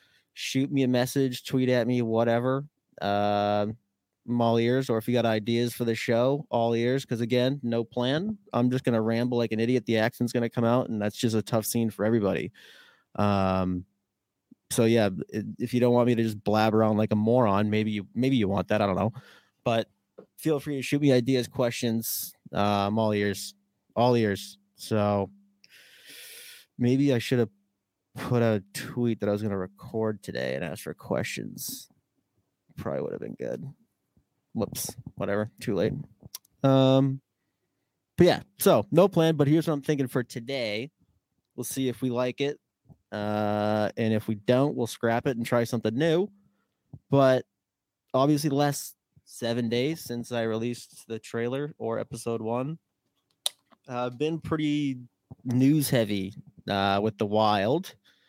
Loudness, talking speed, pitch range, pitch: -27 LUFS, 170 wpm, 105-130 Hz, 120 Hz